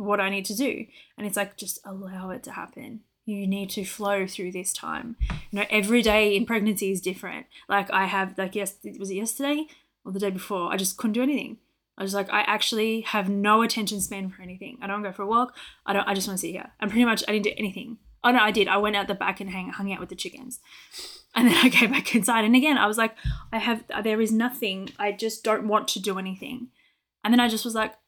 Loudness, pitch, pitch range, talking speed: -25 LUFS, 210 Hz, 195-235 Hz, 260 wpm